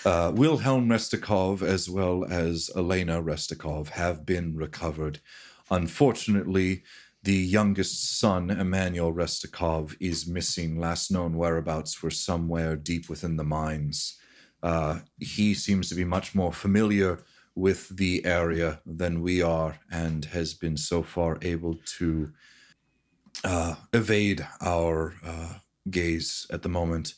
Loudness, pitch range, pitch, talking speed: -27 LUFS, 80-95 Hz, 85 Hz, 125 wpm